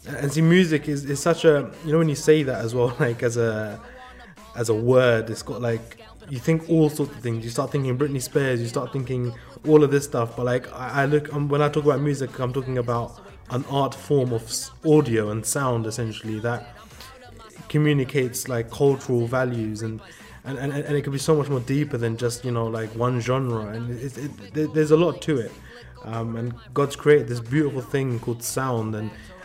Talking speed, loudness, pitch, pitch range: 215 wpm, -23 LUFS, 130 Hz, 115-145 Hz